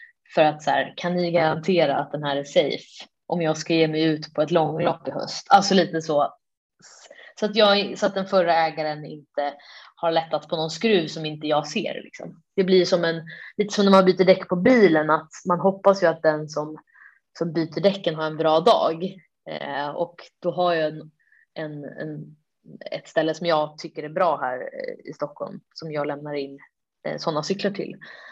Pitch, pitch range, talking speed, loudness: 165 Hz, 155-185 Hz, 205 wpm, -22 LUFS